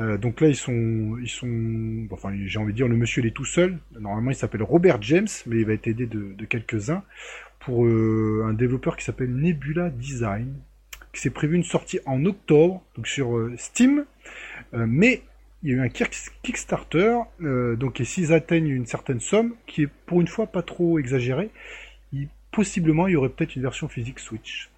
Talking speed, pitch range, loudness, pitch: 200 wpm, 115-170 Hz, -24 LUFS, 135 Hz